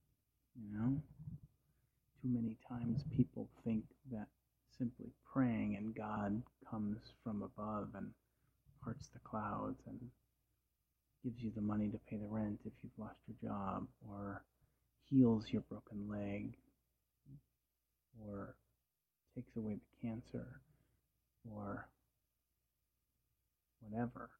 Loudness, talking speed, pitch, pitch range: -43 LUFS, 110 wpm, 110 Hz, 105-125 Hz